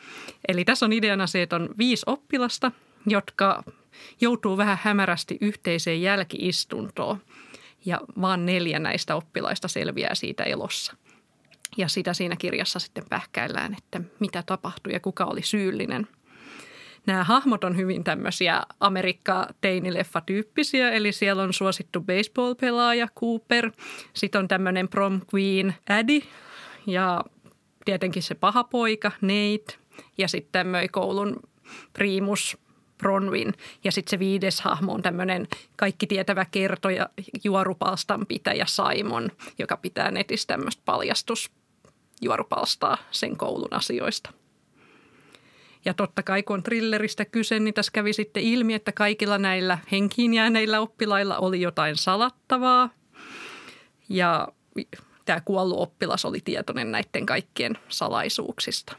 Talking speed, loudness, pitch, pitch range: 120 wpm, -25 LUFS, 195 Hz, 185-215 Hz